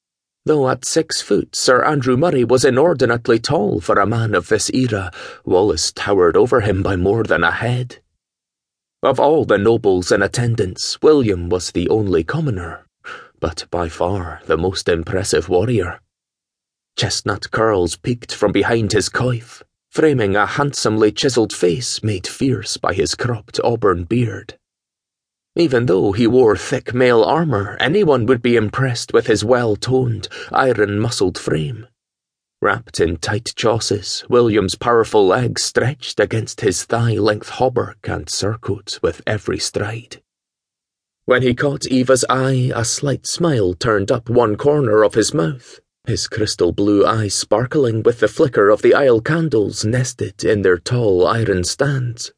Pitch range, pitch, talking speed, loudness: 105-130 Hz, 120 Hz, 145 wpm, -17 LUFS